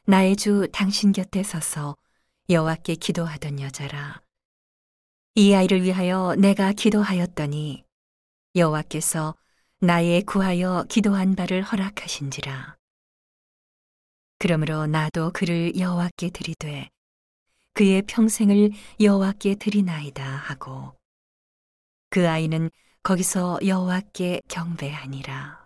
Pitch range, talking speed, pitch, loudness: 150-195 Hz, 240 characters per minute, 175 Hz, -23 LUFS